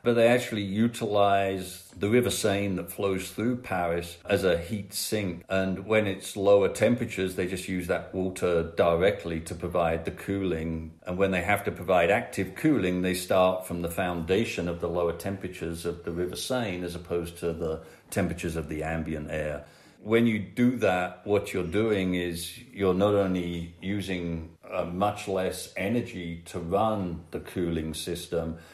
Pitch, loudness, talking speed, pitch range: 90 Hz, -28 LUFS, 165 wpm, 85-100 Hz